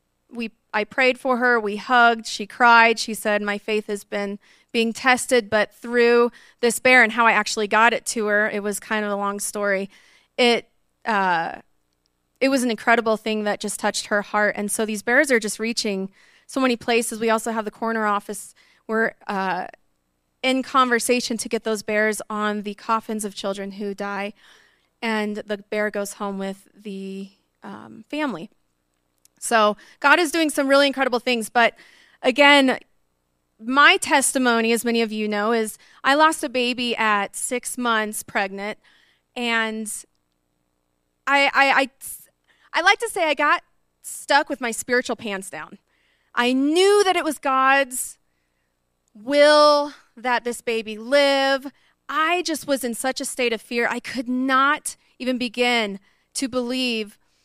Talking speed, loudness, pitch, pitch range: 165 wpm, -20 LUFS, 230 Hz, 205-255 Hz